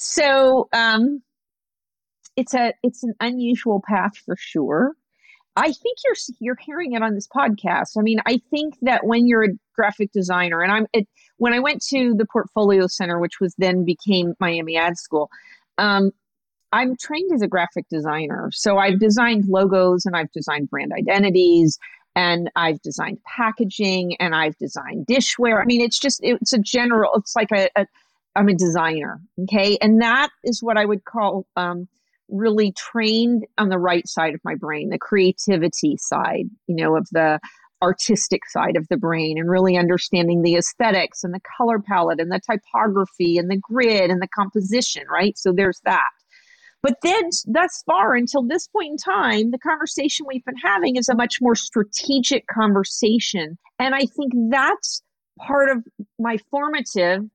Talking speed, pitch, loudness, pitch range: 175 wpm, 215 Hz, -20 LUFS, 185-250 Hz